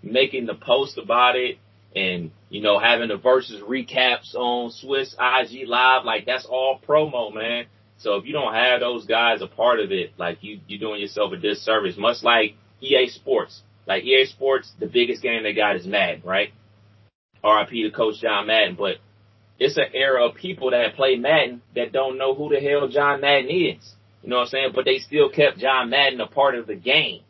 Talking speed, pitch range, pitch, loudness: 205 wpm, 105-135 Hz, 125 Hz, -21 LUFS